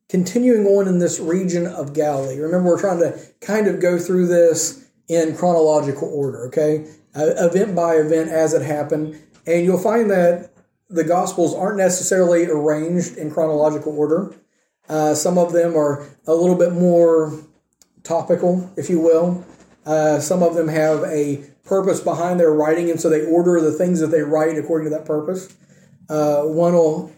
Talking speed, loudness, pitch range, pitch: 170 wpm, -18 LUFS, 155-180 Hz, 165 Hz